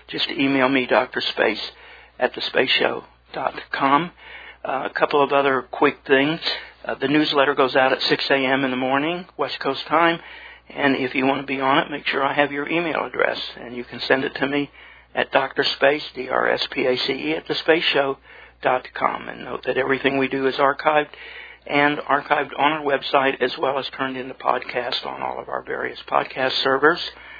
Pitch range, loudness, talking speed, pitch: 135-145 Hz, -21 LUFS, 195 wpm, 140 Hz